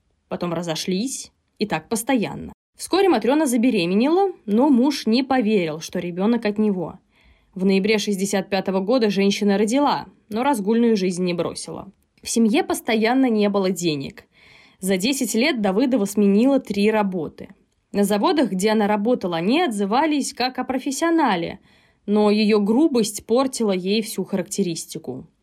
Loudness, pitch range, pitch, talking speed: -20 LUFS, 195-255 Hz, 215 Hz, 135 wpm